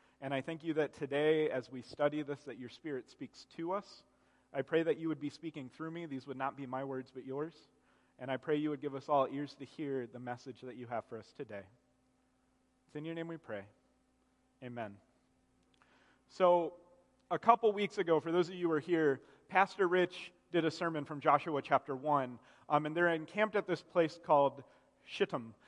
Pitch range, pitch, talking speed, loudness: 130-165 Hz, 145 Hz, 210 wpm, -35 LUFS